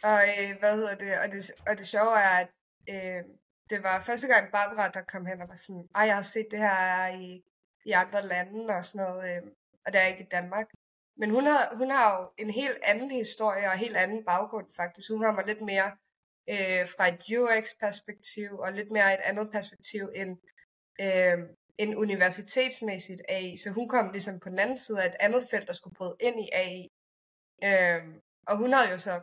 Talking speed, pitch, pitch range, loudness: 210 wpm, 200 Hz, 185-215 Hz, -28 LUFS